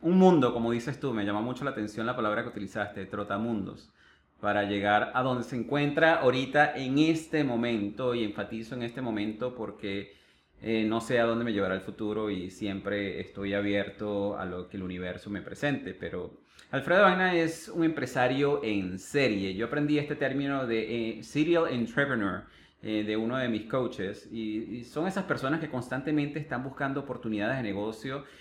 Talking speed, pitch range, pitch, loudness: 180 wpm, 105-140 Hz, 115 Hz, -30 LUFS